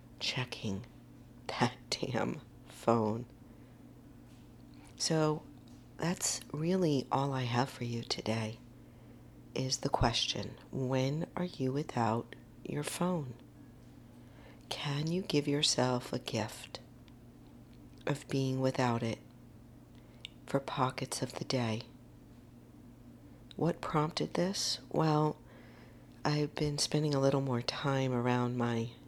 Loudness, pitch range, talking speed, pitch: -34 LUFS, 115-145 Hz, 105 wpm, 130 Hz